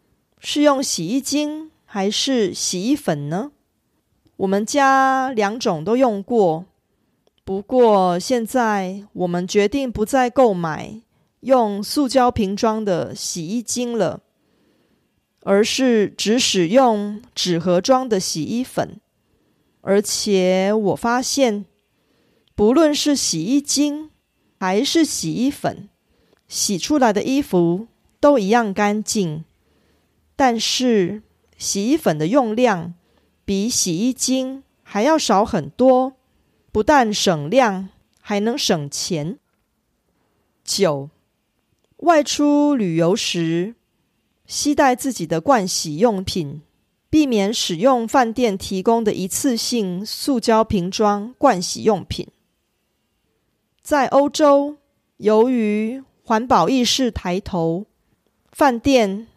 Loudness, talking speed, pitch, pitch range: -19 LUFS, 155 characters per minute, 220 Hz, 195-265 Hz